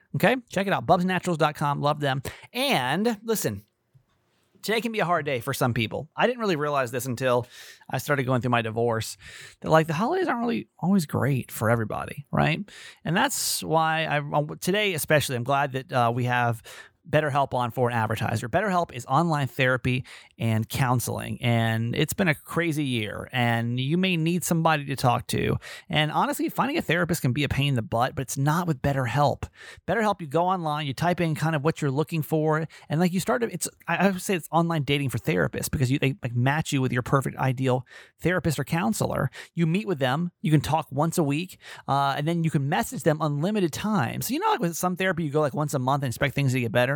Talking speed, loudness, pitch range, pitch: 220 wpm, -25 LUFS, 130-170 Hz, 150 Hz